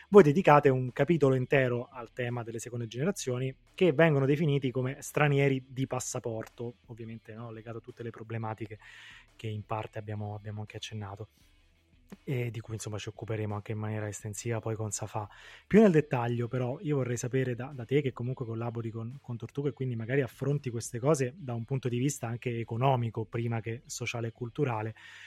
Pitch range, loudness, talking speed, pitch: 110-135 Hz, -31 LUFS, 185 wpm, 120 Hz